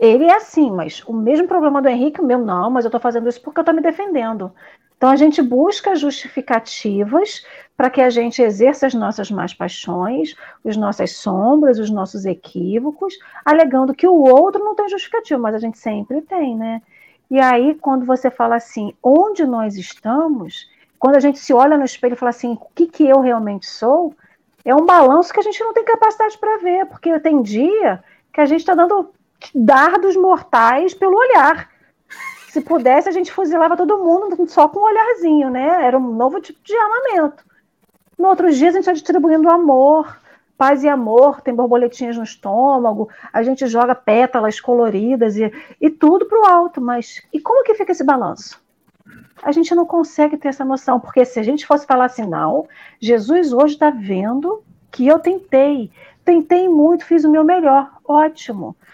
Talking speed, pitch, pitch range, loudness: 185 wpm, 285 Hz, 245-345 Hz, -15 LUFS